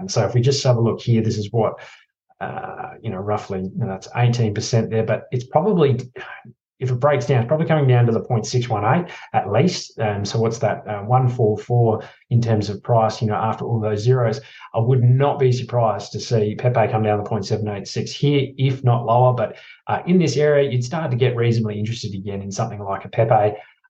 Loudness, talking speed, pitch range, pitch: -20 LUFS, 215 wpm, 105-130 Hz, 115 Hz